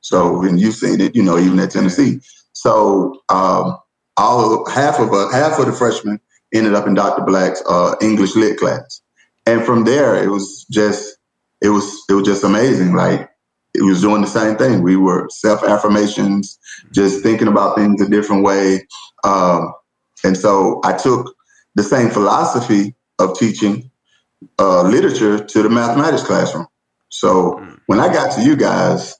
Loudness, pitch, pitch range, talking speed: -14 LUFS, 105 Hz, 100-110 Hz, 165 wpm